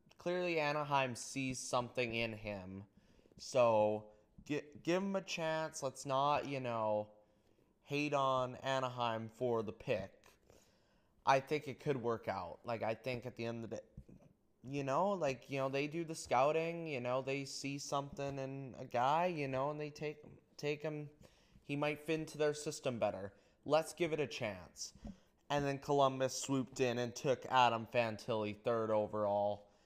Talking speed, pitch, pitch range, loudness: 170 wpm, 135 Hz, 115-150 Hz, -38 LUFS